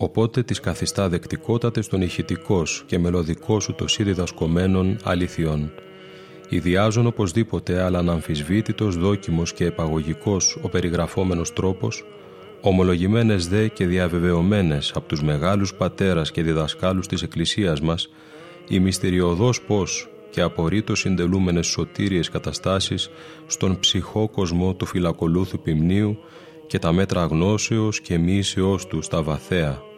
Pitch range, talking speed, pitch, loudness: 85-105 Hz, 120 wpm, 95 Hz, -22 LUFS